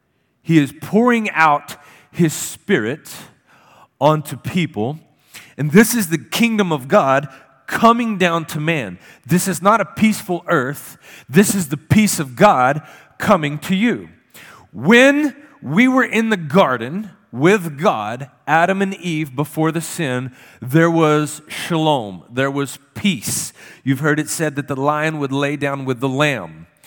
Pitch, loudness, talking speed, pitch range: 155 Hz, -17 LUFS, 150 wpm, 140-195 Hz